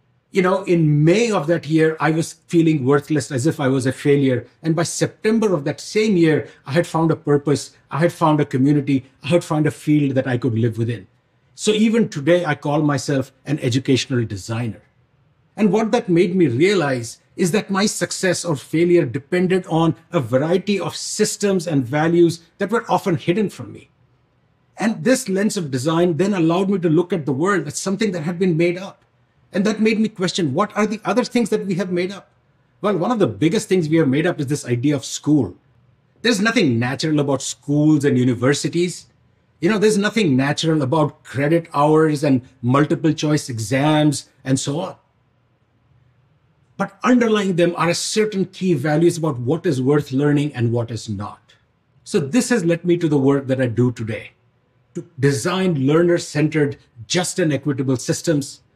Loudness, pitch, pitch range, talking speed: -19 LUFS, 155 Hz, 135-180 Hz, 190 wpm